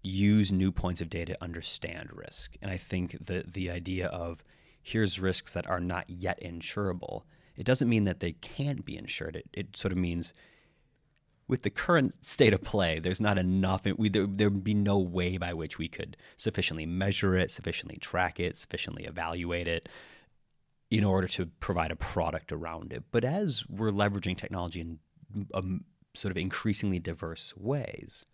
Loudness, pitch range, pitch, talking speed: -31 LUFS, 85-105 Hz, 95 Hz, 175 wpm